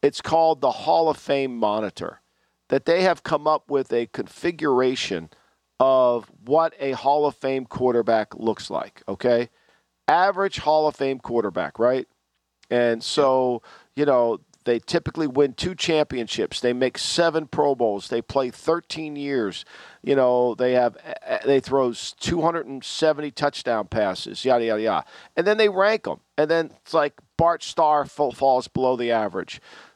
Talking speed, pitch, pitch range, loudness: 150 wpm, 135 Hz, 120-155 Hz, -23 LUFS